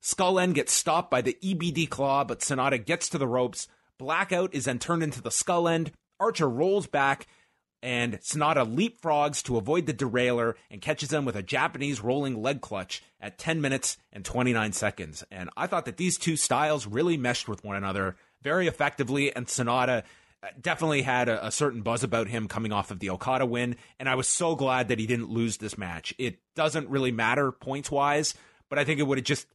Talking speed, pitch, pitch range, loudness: 205 wpm, 135 Hz, 115-150 Hz, -28 LUFS